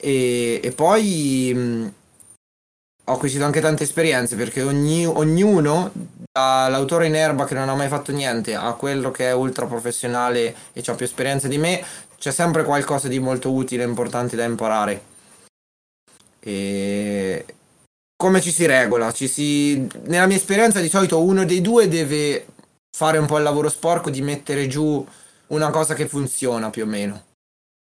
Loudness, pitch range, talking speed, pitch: -20 LUFS, 120-155 Hz, 160 wpm, 140 Hz